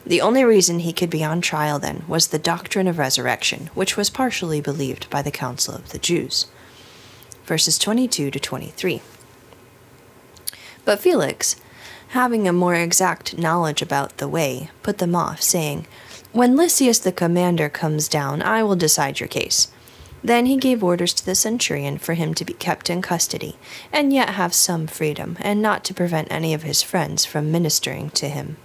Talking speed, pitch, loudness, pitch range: 175 wpm, 170 Hz, -20 LUFS, 150-195 Hz